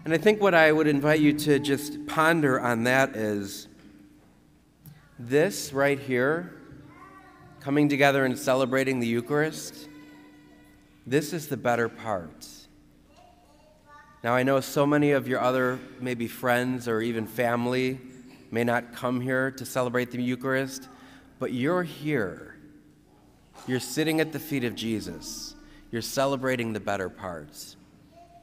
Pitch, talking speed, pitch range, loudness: 130 Hz, 135 wpm, 115-145 Hz, -26 LUFS